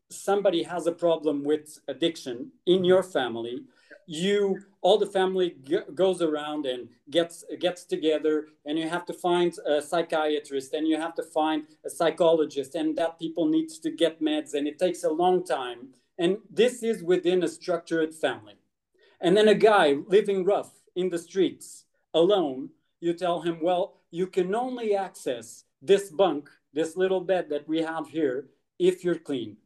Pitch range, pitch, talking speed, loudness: 155-185 Hz, 170 Hz, 170 wpm, -26 LUFS